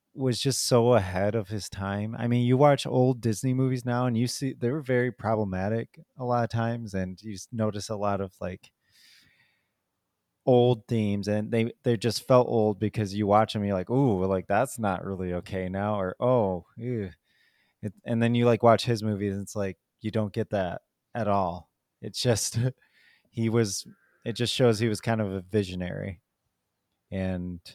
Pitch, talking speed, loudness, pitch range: 110 Hz, 190 wpm, -27 LUFS, 100-120 Hz